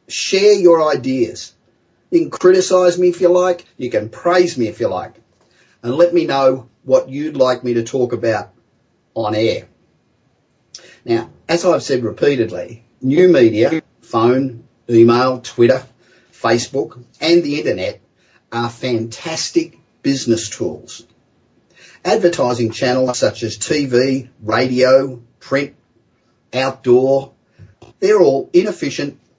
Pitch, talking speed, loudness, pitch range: 130 Hz, 120 wpm, -16 LUFS, 120-170 Hz